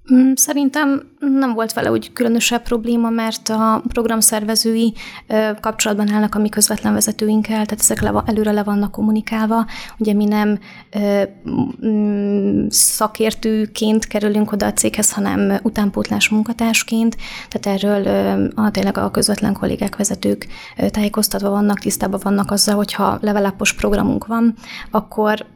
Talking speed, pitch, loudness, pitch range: 120 wpm, 215 Hz, -17 LUFS, 205-230 Hz